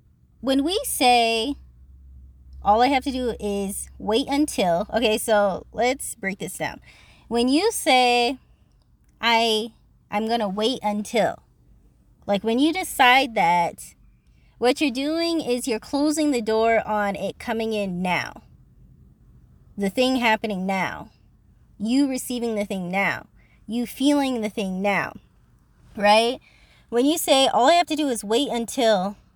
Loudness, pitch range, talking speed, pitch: -22 LUFS, 200-260 Hz, 145 wpm, 225 Hz